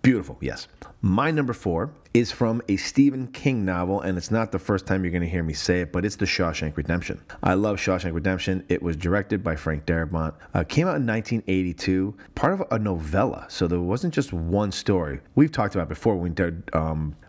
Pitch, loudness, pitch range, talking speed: 95 Hz, -25 LUFS, 85-105 Hz, 215 wpm